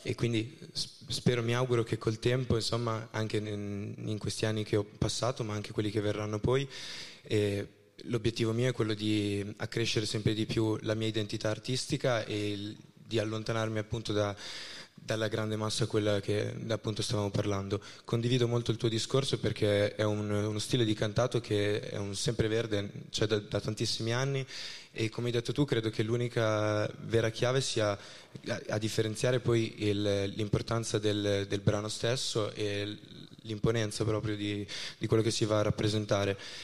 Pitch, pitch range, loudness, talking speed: 110 Hz, 105-120 Hz, -32 LUFS, 170 wpm